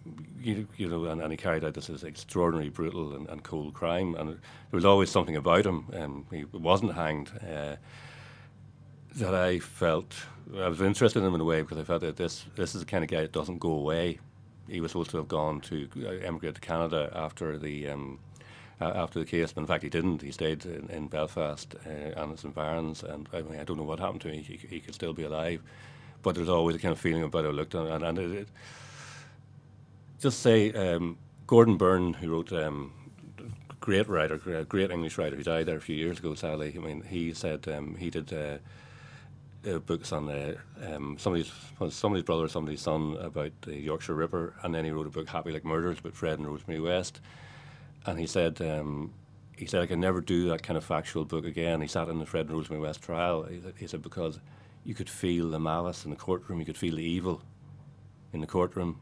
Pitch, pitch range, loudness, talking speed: 85 Hz, 80-100 Hz, -31 LUFS, 230 wpm